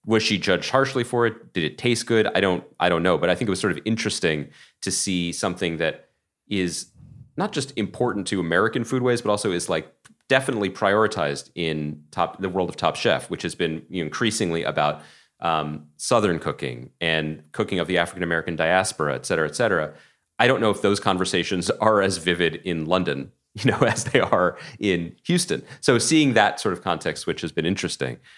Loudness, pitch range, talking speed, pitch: -23 LUFS, 85-115 Hz, 200 wpm, 95 Hz